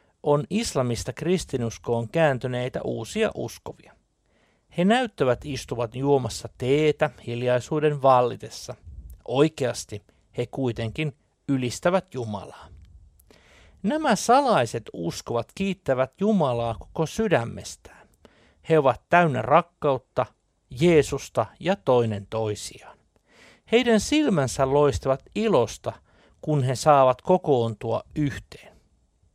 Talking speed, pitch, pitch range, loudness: 85 wpm, 130 Hz, 115-155 Hz, -24 LUFS